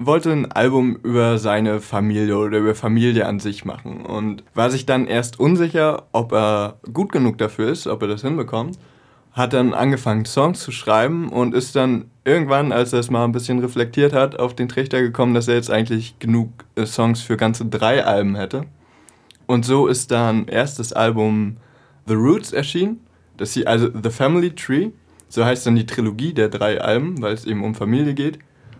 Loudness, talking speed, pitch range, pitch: -19 LUFS, 185 wpm, 110-130 Hz, 120 Hz